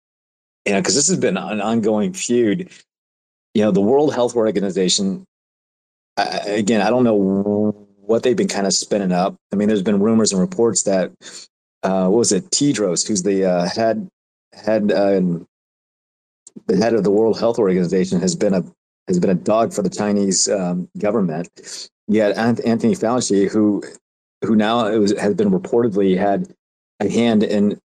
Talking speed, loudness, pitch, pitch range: 170 wpm, -18 LUFS, 105 Hz, 95-120 Hz